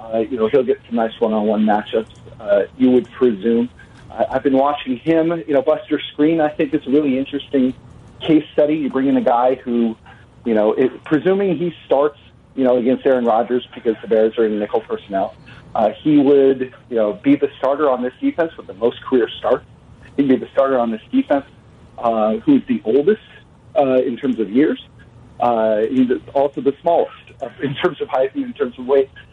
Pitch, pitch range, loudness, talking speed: 130 Hz, 120-150 Hz, -18 LUFS, 205 wpm